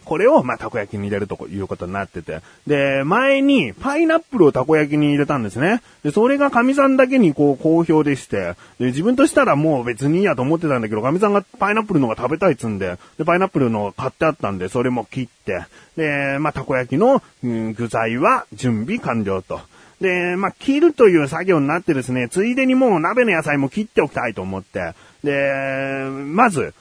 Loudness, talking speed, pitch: -18 LUFS, 410 characters per minute, 145 Hz